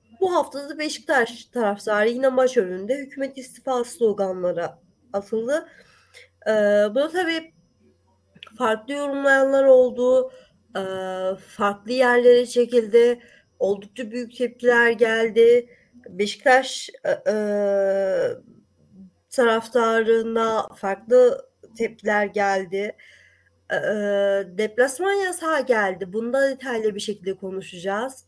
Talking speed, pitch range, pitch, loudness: 90 wpm, 205-260 Hz, 235 Hz, -21 LUFS